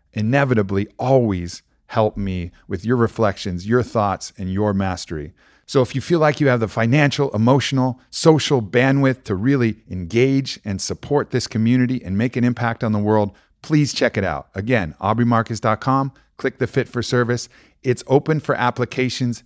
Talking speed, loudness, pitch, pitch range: 165 wpm, -20 LUFS, 120 Hz, 105-130 Hz